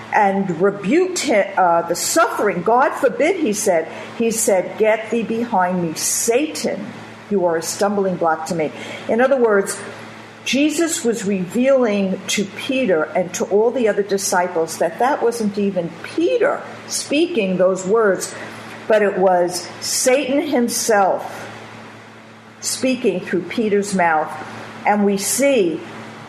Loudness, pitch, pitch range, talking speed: -18 LUFS, 200 Hz, 175-235 Hz, 130 wpm